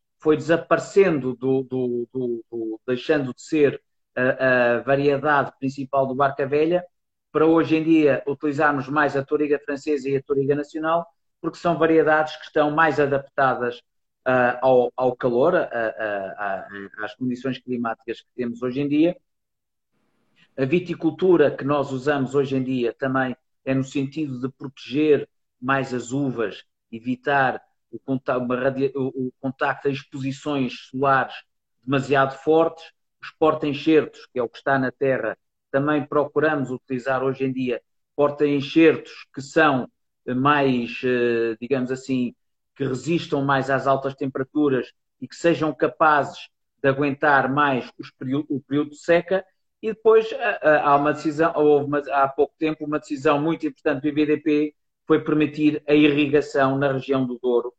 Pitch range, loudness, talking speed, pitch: 130-150 Hz, -22 LUFS, 145 wpm, 140 Hz